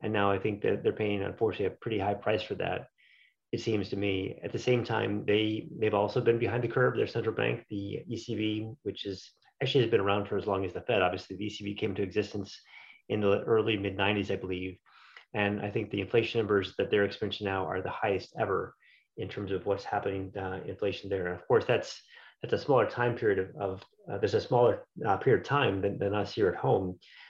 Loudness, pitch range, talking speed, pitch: -31 LUFS, 100-110 Hz, 235 wpm, 105 Hz